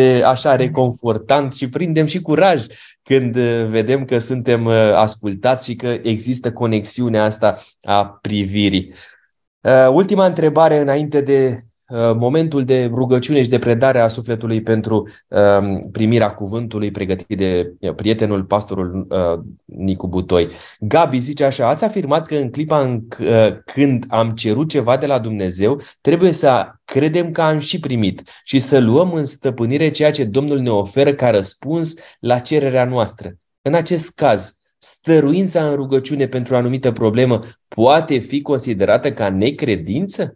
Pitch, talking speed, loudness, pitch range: 125 Hz, 145 wpm, -16 LUFS, 110-140 Hz